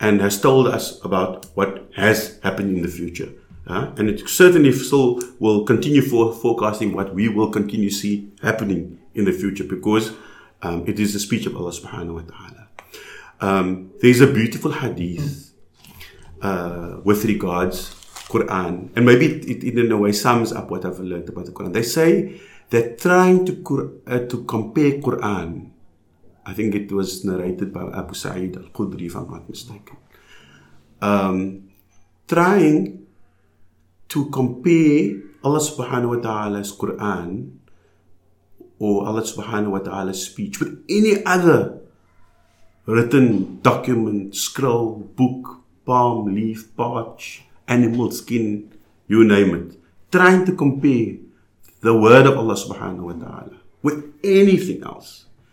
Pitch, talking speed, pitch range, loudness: 105 Hz, 140 wpm, 95-125 Hz, -19 LUFS